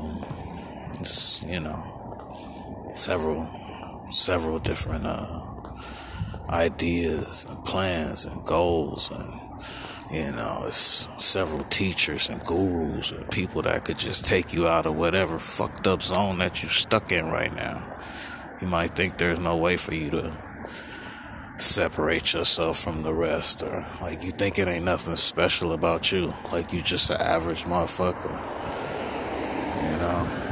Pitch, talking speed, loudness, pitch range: 85 Hz, 140 wpm, -21 LUFS, 80-90 Hz